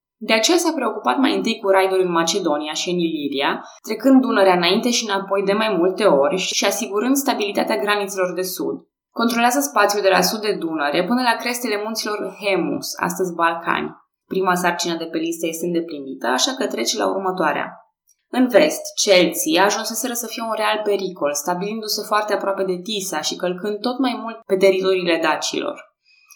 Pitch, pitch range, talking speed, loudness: 200 Hz, 180-220 Hz, 175 wpm, -19 LUFS